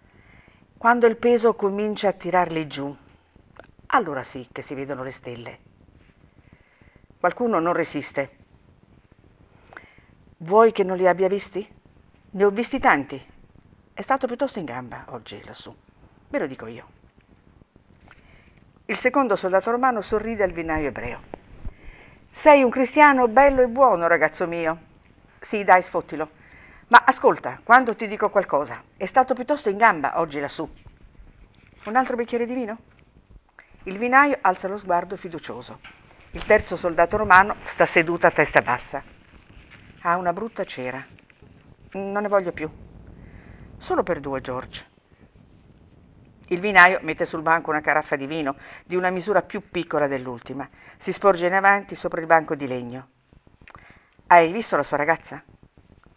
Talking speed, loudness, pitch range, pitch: 140 wpm, -21 LUFS, 140-210 Hz, 175 Hz